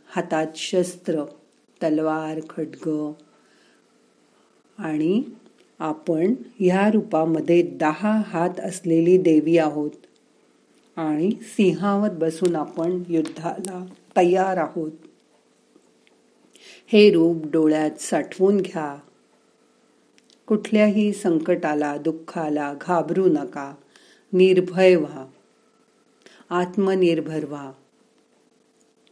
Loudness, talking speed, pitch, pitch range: -22 LUFS, 70 wpm, 170 Hz, 155-190 Hz